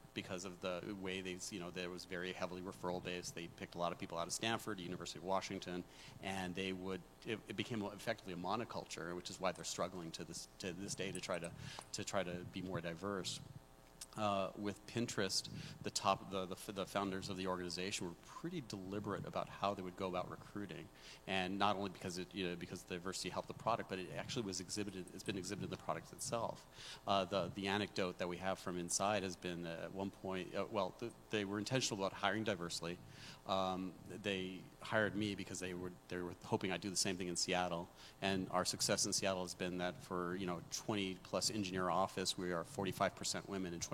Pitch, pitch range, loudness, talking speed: 95 Hz, 90-100 Hz, -42 LUFS, 220 wpm